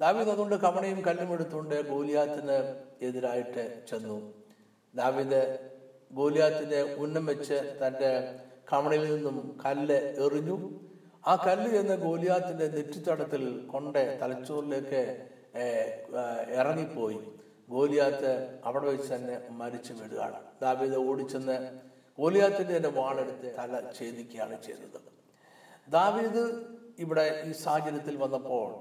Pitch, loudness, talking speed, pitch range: 140 Hz, -31 LUFS, 95 wpm, 130-155 Hz